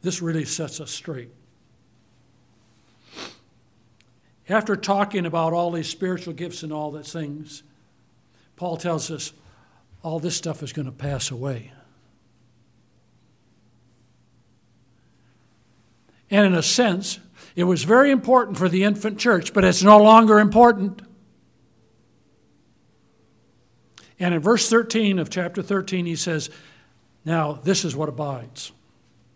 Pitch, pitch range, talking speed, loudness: 155 Hz, 120-185 Hz, 120 wpm, -20 LUFS